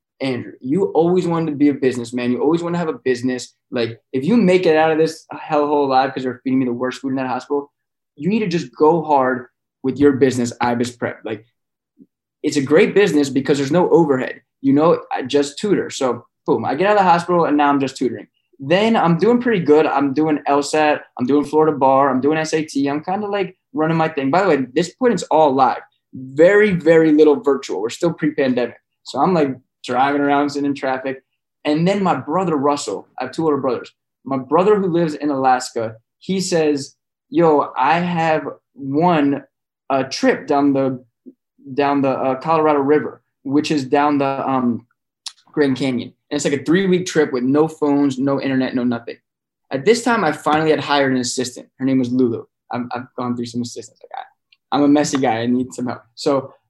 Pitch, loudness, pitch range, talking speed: 145 Hz, -18 LUFS, 130-160 Hz, 215 wpm